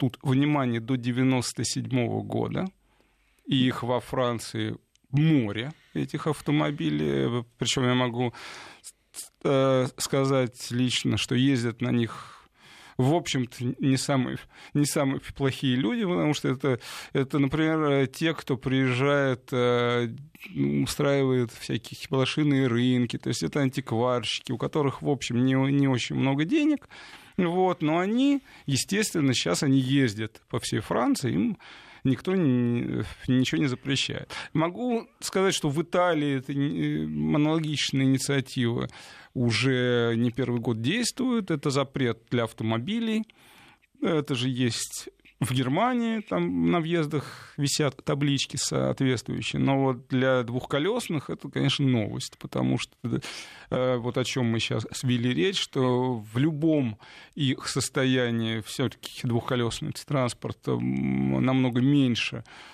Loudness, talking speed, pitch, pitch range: -26 LUFS, 120 wpm, 130 Hz, 120-145 Hz